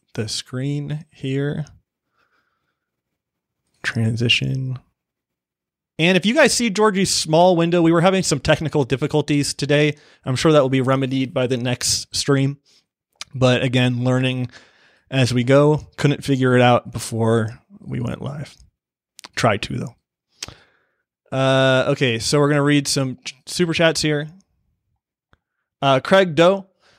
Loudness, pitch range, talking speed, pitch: -18 LUFS, 125-155 Hz, 135 wpm, 140 Hz